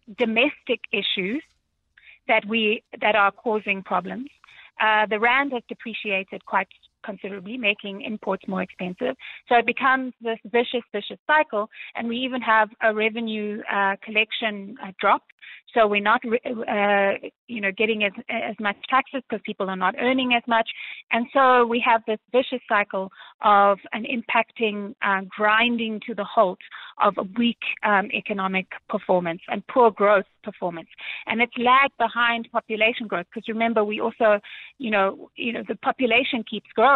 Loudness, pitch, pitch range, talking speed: -23 LUFS, 220 Hz, 205-240 Hz, 160 wpm